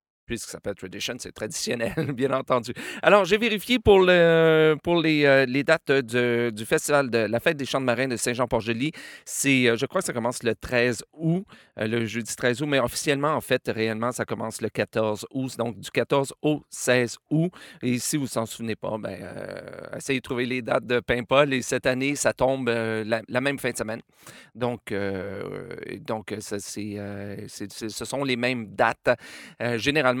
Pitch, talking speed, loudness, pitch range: 125 Hz, 205 wpm, -24 LUFS, 115-145 Hz